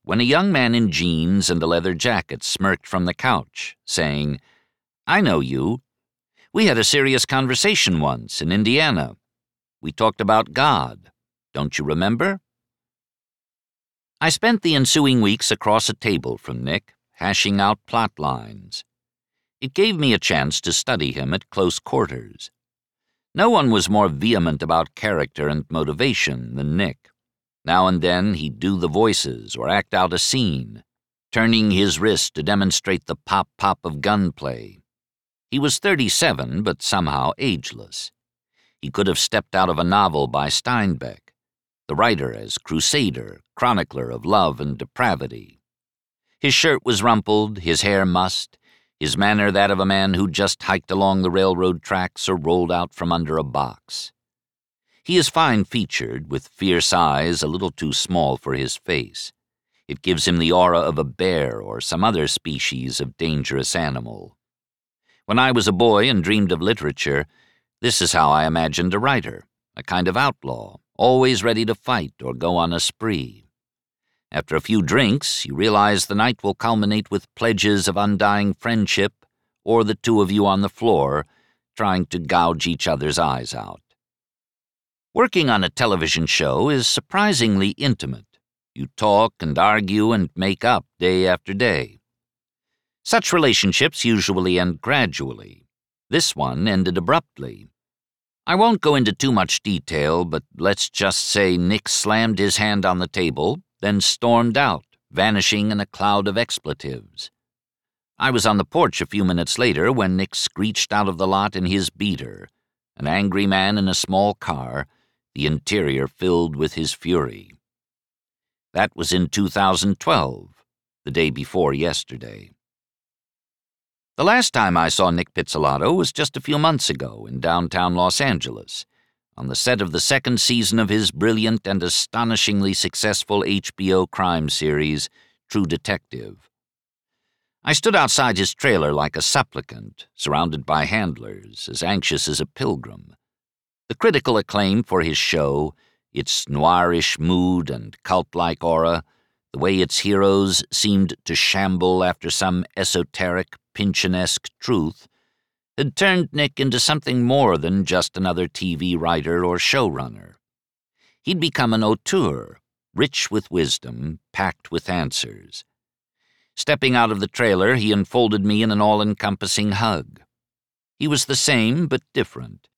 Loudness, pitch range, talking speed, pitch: -19 LUFS, 85-110 Hz, 155 wpm, 95 Hz